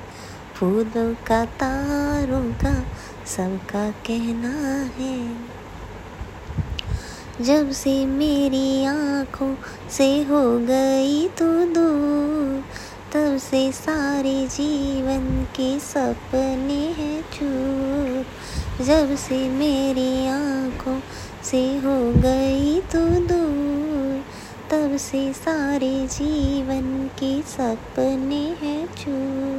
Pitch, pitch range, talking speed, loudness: 270 Hz, 260-285 Hz, 80 wpm, -22 LUFS